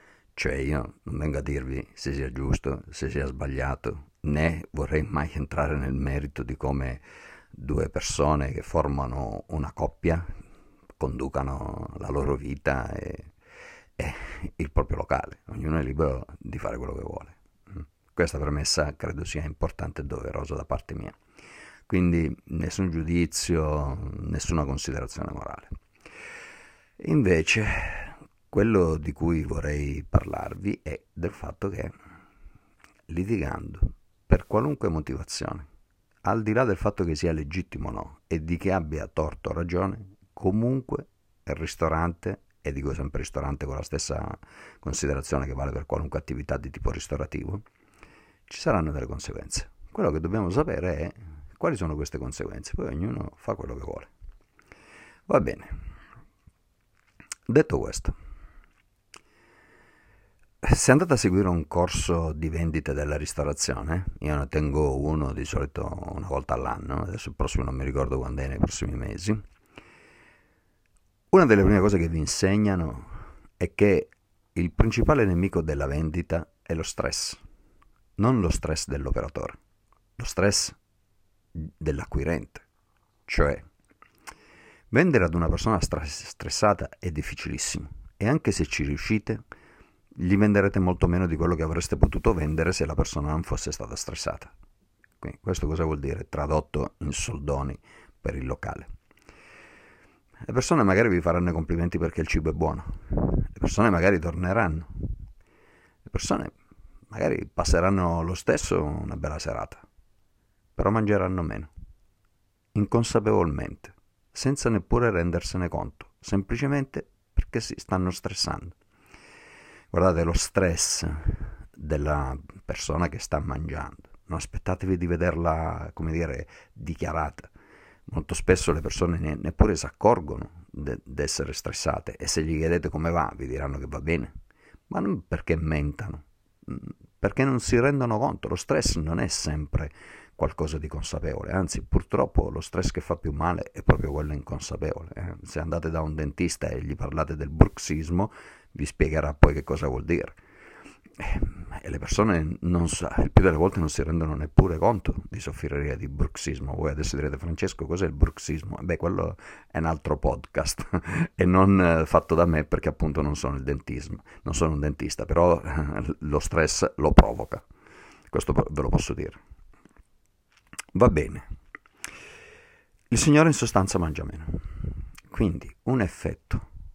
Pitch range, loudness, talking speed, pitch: 75-95 Hz, -27 LUFS, 140 wpm, 80 Hz